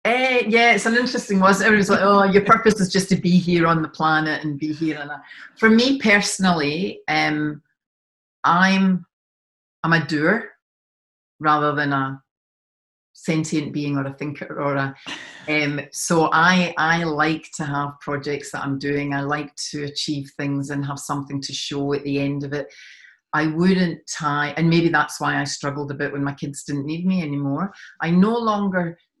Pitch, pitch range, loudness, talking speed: 155 Hz, 145-180 Hz, -20 LUFS, 185 wpm